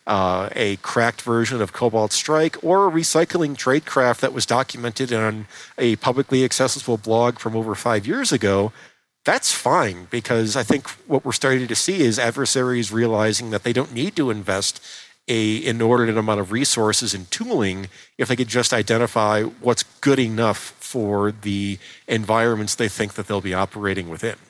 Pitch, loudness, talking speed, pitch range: 115 Hz, -20 LUFS, 165 wpm, 105-125 Hz